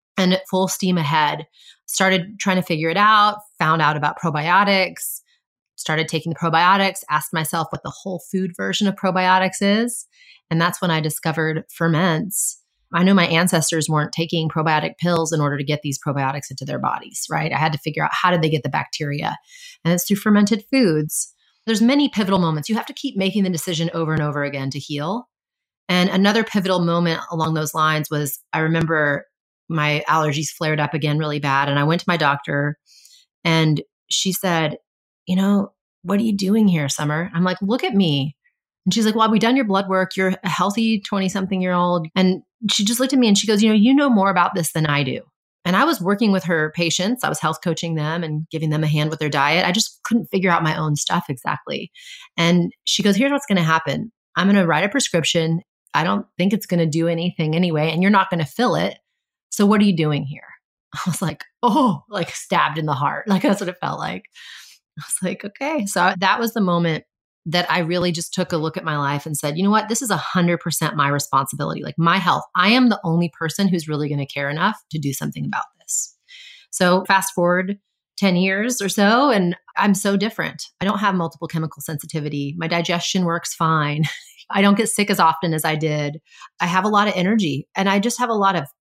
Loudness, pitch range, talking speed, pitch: -19 LUFS, 160-200 Hz, 225 wpm, 175 Hz